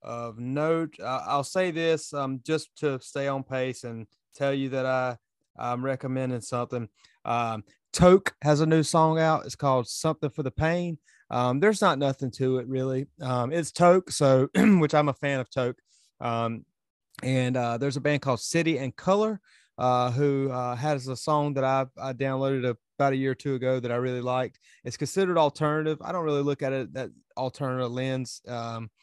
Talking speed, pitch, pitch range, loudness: 190 wpm, 135 Hz, 125-150 Hz, -27 LUFS